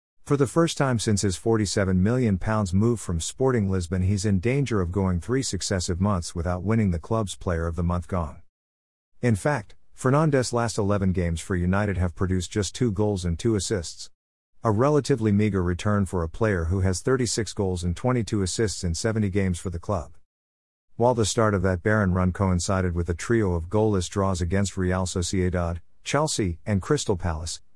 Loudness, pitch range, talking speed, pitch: -25 LUFS, 90-110 Hz, 185 wpm, 95 Hz